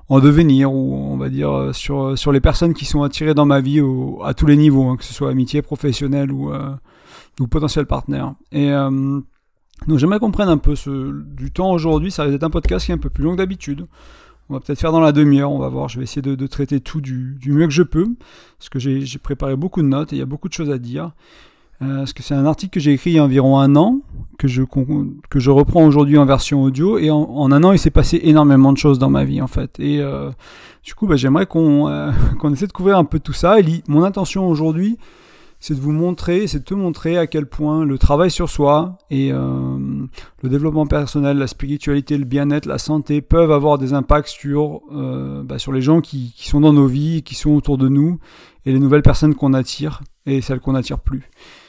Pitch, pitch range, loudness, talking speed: 145 Hz, 135-155 Hz, -16 LUFS, 250 wpm